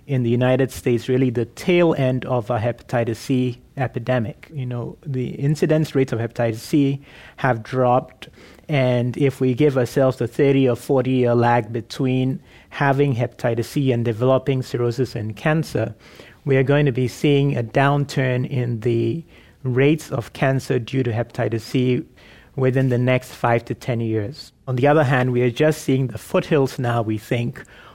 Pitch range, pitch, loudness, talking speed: 120-140 Hz, 130 Hz, -20 LUFS, 170 wpm